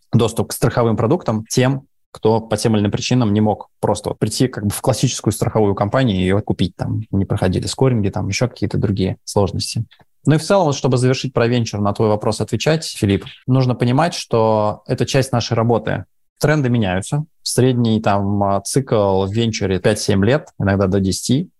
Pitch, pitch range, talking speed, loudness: 115 Hz, 105-130 Hz, 185 wpm, -18 LUFS